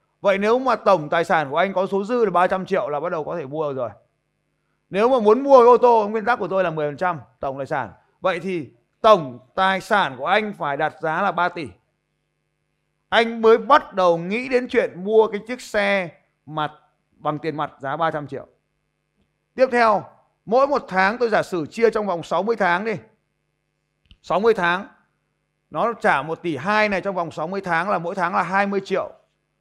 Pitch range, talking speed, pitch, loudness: 165-220 Hz, 205 wpm, 190 Hz, -20 LUFS